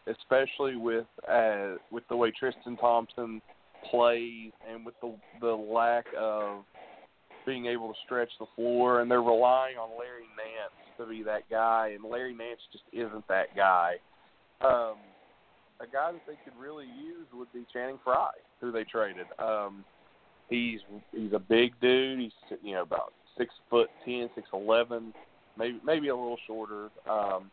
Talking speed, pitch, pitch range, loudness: 160 wpm, 115 Hz, 110-120 Hz, -30 LUFS